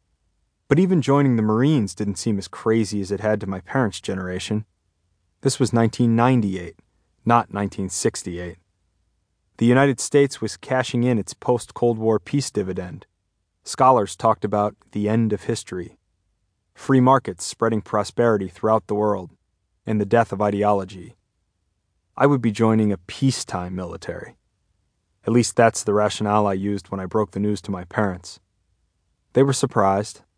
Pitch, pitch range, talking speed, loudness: 105 Hz, 95-115 Hz, 150 wpm, -21 LUFS